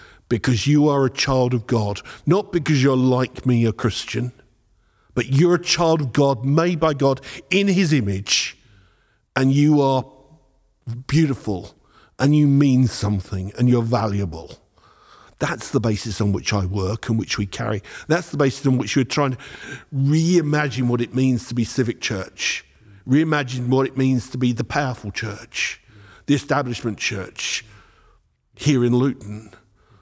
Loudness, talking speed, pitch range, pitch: -20 LUFS, 160 wpm, 110-140 Hz, 125 Hz